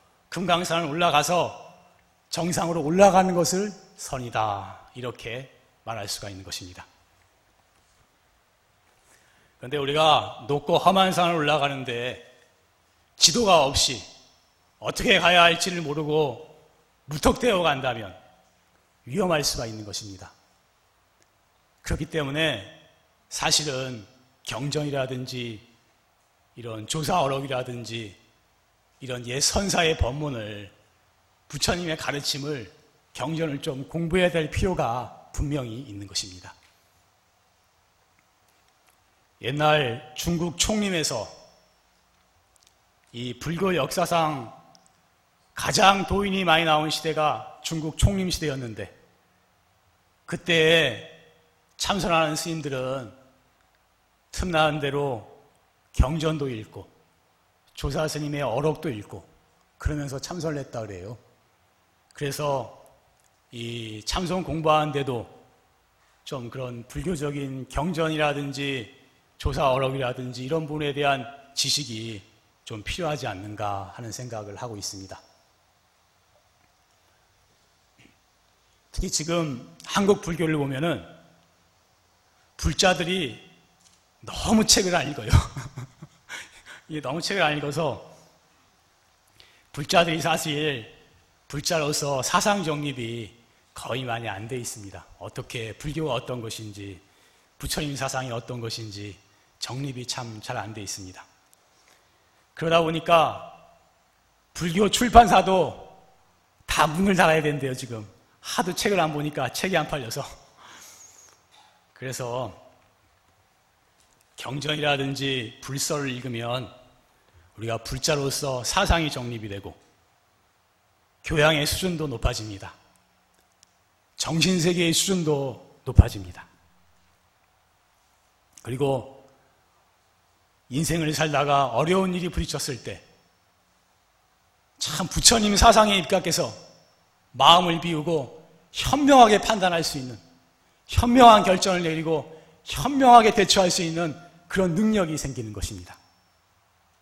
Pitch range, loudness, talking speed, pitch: 105-160 Hz, -24 LUFS, 220 characters per minute, 135 Hz